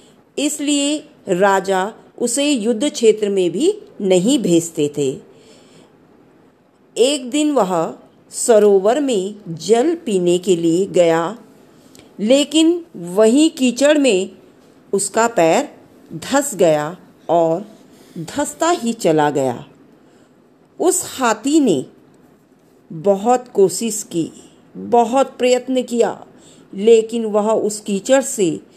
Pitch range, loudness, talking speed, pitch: 185-270 Hz, -17 LUFS, 100 wpm, 225 Hz